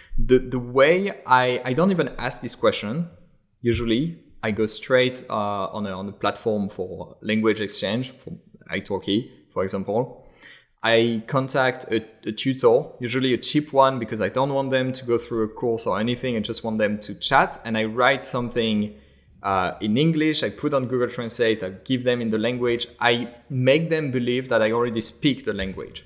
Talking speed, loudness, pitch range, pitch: 190 wpm, -23 LUFS, 110-130 Hz, 120 Hz